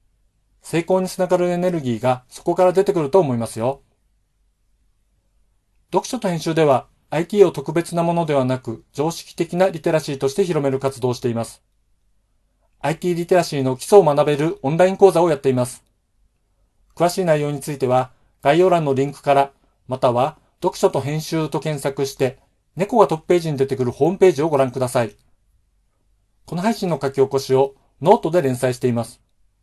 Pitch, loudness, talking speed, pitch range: 140 Hz, -19 LUFS, 360 characters per minute, 120-170 Hz